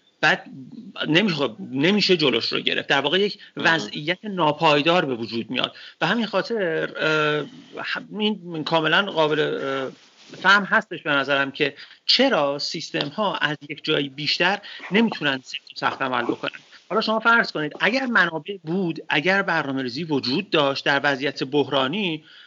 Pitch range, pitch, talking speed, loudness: 145-190 Hz, 155 Hz, 135 wpm, -22 LUFS